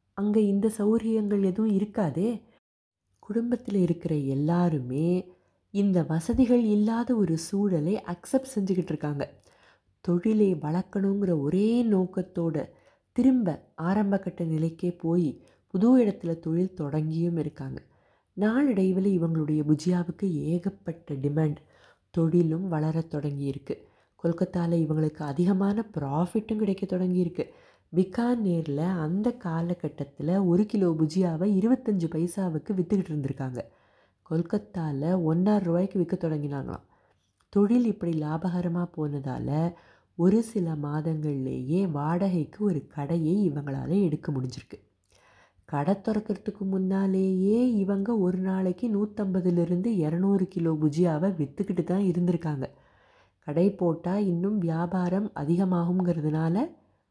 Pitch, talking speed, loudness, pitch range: 180 Hz, 95 wpm, -27 LUFS, 160-200 Hz